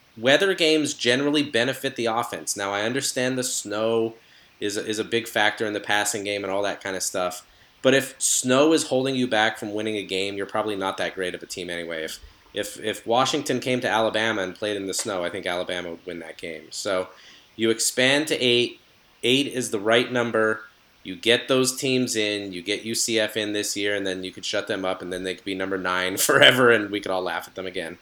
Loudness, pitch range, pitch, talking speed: -23 LUFS, 100-125 Hz, 110 Hz, 235 wpm